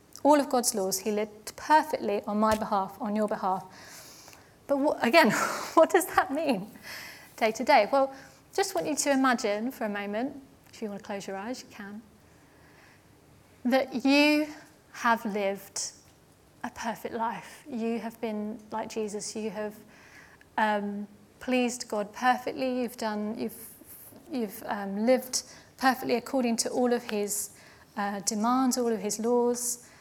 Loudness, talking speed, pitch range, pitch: -28 LUFS, 155 wpm, 210-255 Hz, 230 Hz